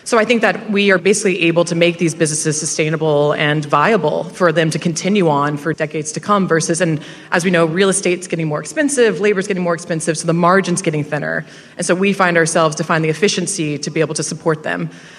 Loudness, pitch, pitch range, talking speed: -16 LUFS, 170 Hz, 160-190 Hz, 230 wpm